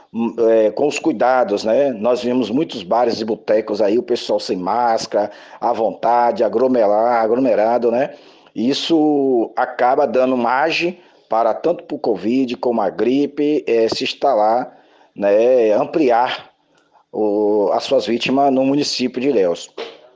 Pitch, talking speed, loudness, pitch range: 130 Hz, 135 wpm, -17 LUFS, 115-150 Hz